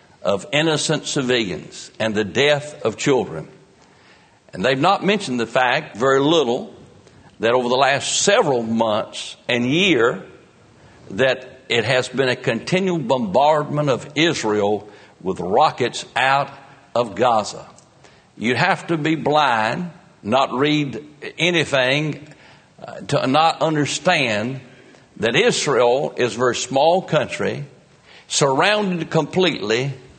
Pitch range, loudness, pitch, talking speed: 125-160 Hz, -19 LUFS, 145 Hz, 120 wpm